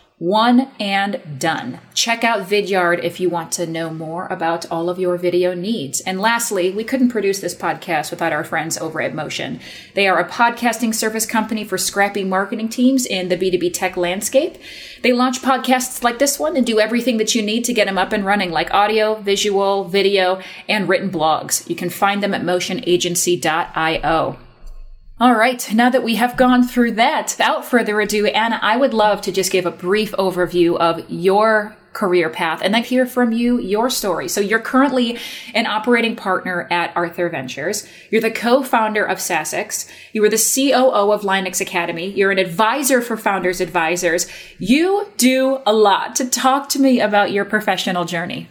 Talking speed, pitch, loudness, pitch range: 185 wpm, 205 Hz, -17 LUFS, 180-235 Hz